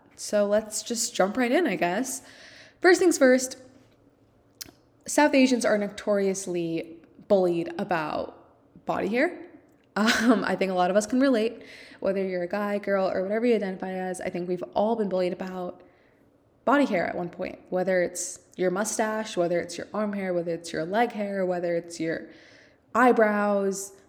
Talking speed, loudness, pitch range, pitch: 170 wpm, -26 LUFS, 180-235 Hz, 205 Hz